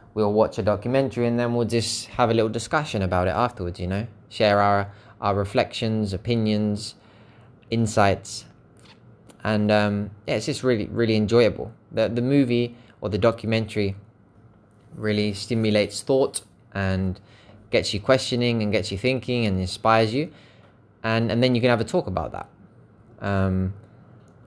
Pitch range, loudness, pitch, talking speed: 105-120 Hz, -23 LUFS, 110 Hz, 150 wpm